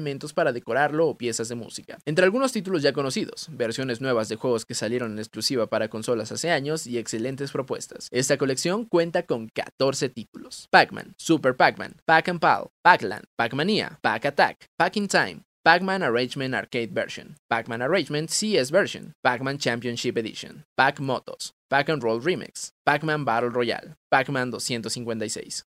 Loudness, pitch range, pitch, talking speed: -24 LUFS, 120-165 Hz, 135 Hz, 145 wpm